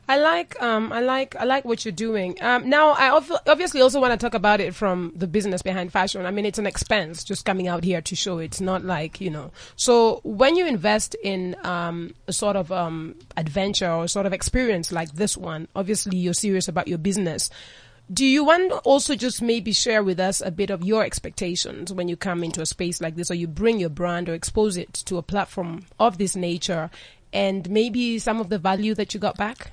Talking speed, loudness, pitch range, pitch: 230 wpm, -23 LUFS, 180-225 Hz, 195 Hz